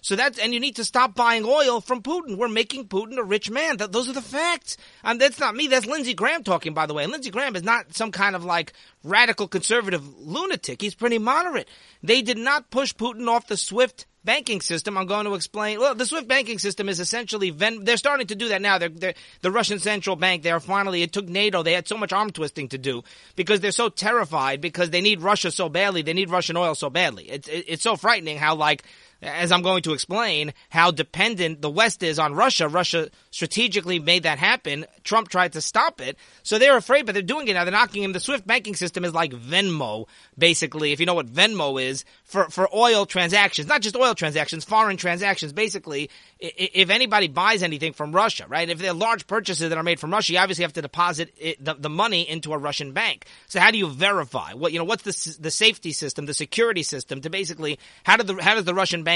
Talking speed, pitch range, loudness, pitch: 235 wpm, 165-225 Hz, -22 LUFS, 190 Hz